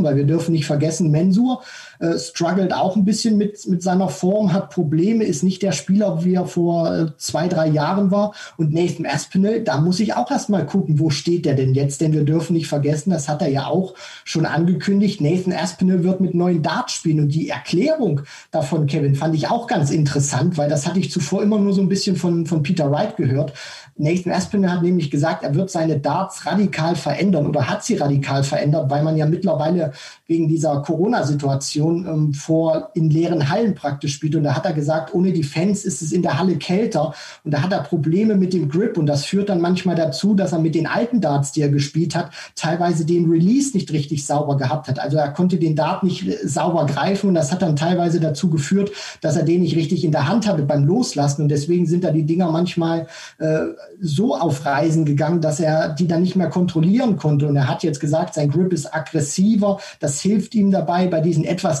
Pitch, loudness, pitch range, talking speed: 165 Hz, -19 LUFS, 155-185 Hz, 215 wpm